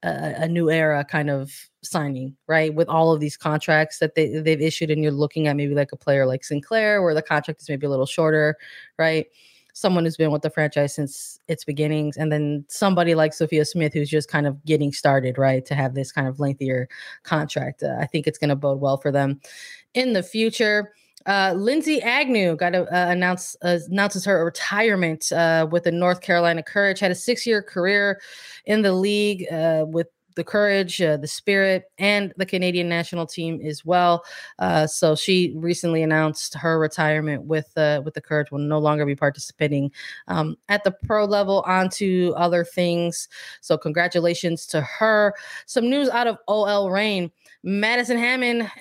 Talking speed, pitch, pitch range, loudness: 190 wpm, 165 Hz, 150-195 Hz, -21 LUFS